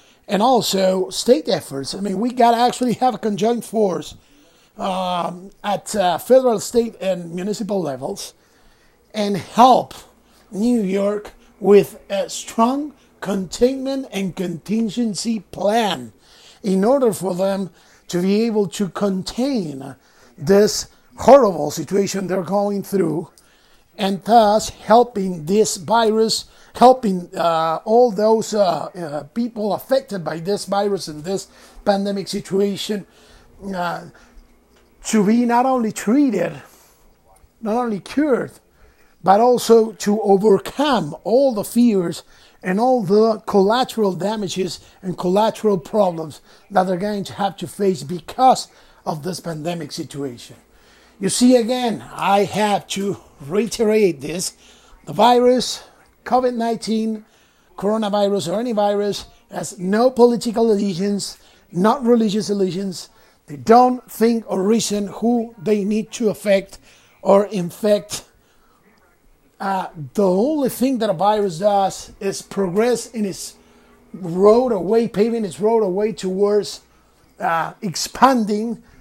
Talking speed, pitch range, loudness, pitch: 120 wpm, 185-225 Hz, -19 LUFS, 205 Hz